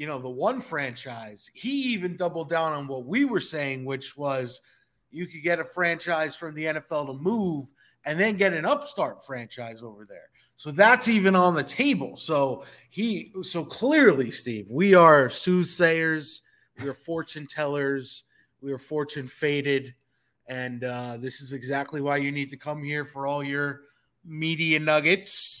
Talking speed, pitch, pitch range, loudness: 170 wpm, 150 Hz, 135-170 Hz, -25 LUFS